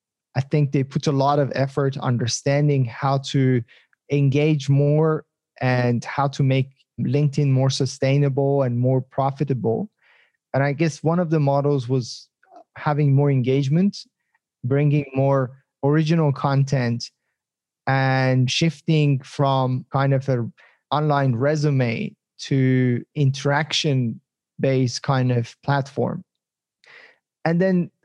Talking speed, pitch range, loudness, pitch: 115 wpm, 130-150 Hz, -21 LUFS, 140 Hz